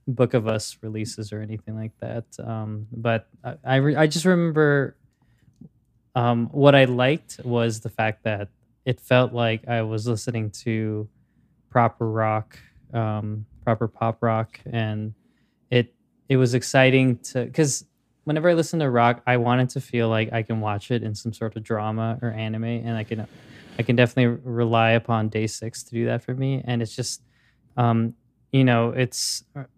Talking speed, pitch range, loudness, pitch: 175 wpm, 110-125 Hz, -23 LUFS, 120 Hz